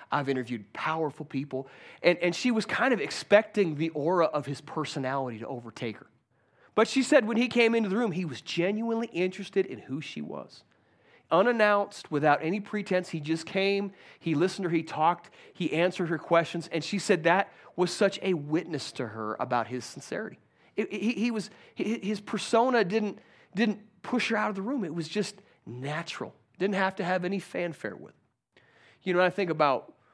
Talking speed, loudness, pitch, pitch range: 195 wpm, -29 LUFS, 180 Hz, 155-205 Hz